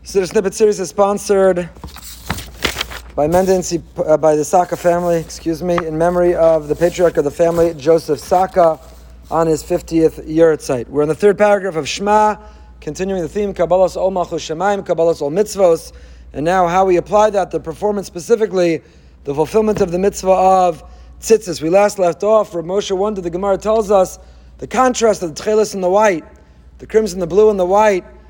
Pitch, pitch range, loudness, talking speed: 180 Hz, 165-205 Hz, -15 LUFS, 190 wpm